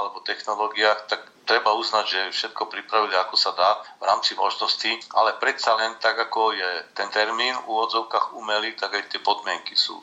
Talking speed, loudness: 180 wpm, -23 LUFS